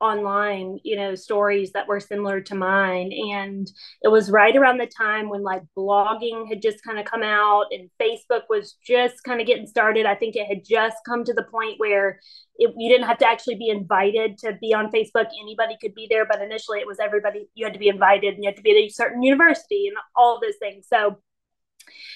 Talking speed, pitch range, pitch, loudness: 230 wpm, 200-230 Hz, 215 Hz, -21 LUFS